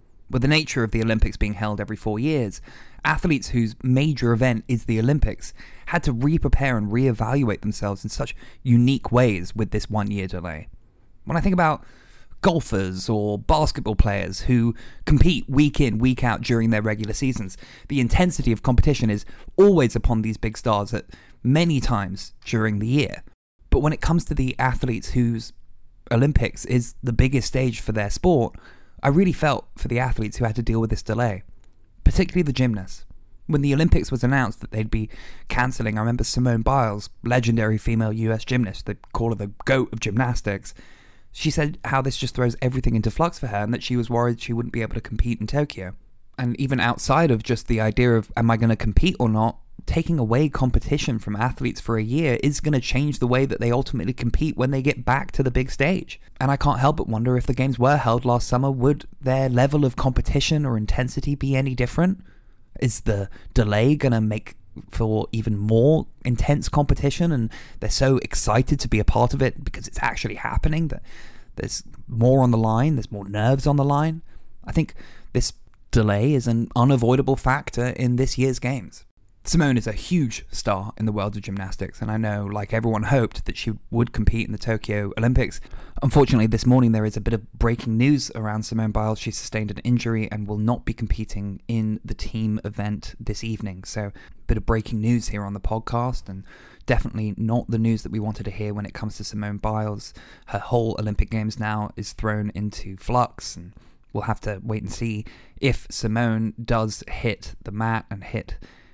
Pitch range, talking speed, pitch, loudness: 105-130 Hz, 200 wpm, 115 Hz, -23 LUFS